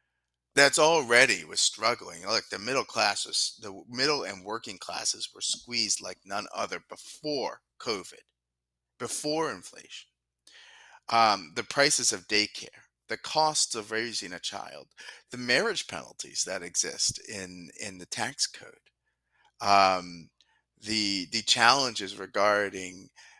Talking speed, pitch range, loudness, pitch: 125 wpm, 90-120 Hz, -27 LUFS, 100 Hz